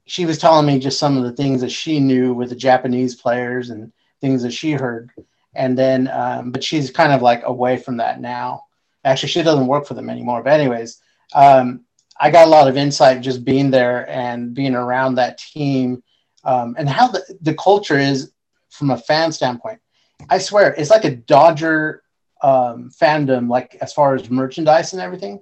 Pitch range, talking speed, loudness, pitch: 125-155 Hz, 195 wpm, -16 LUFS, 135 Hz